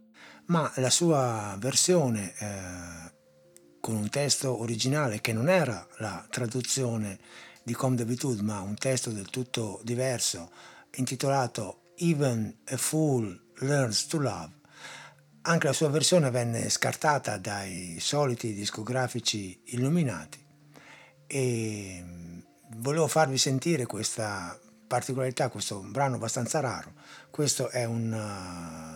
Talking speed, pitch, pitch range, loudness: 110 wpm, 120 Hz, 105-140 Hz, -29 LUFS